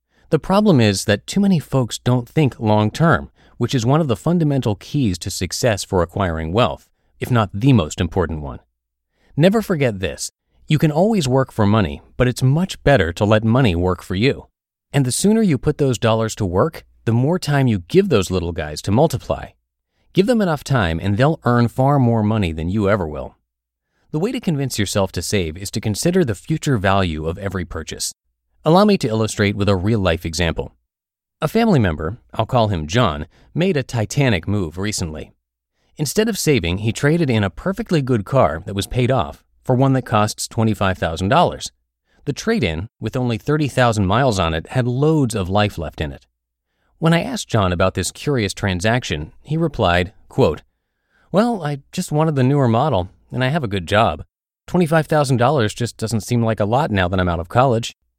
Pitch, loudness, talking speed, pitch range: 110 Hz, -18 LUFS, 195 wpm, 95-140 Hz